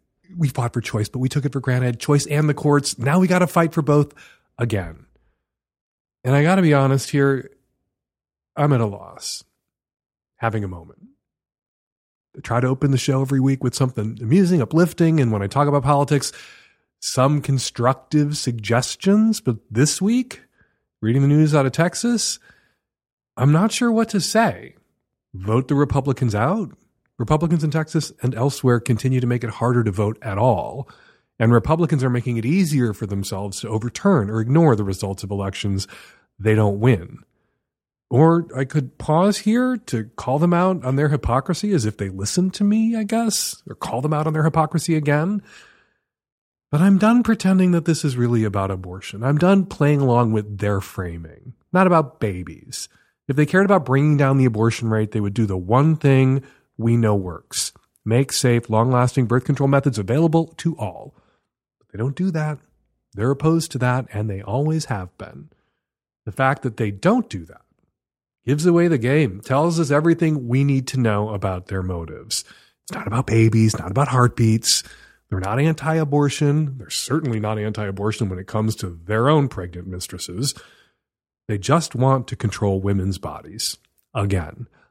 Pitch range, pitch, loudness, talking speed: 110-155 Hz, 130 Hz, -20 LUFS, 180 wpm